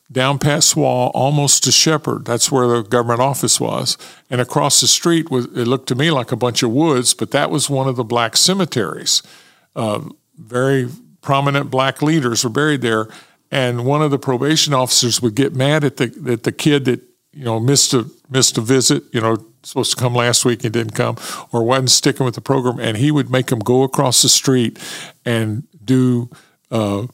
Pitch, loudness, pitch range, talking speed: 130 Hz, -15 LUFS, 120-145 Hz, 205 wpm